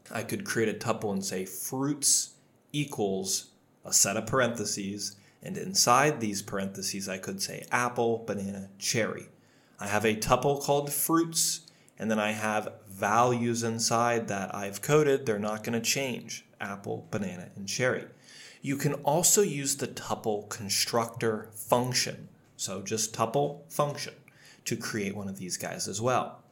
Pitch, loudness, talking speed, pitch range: 115 Hz, -29 LUFS, 150 wpm, 100-140 Hz